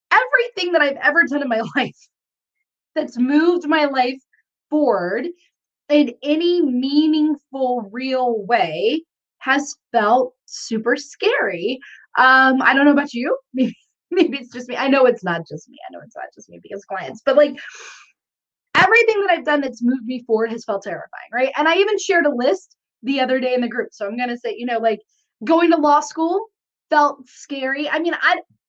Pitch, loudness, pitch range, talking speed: 275 Hz, -18 LUFS, 245-320 Hz, 185 wpm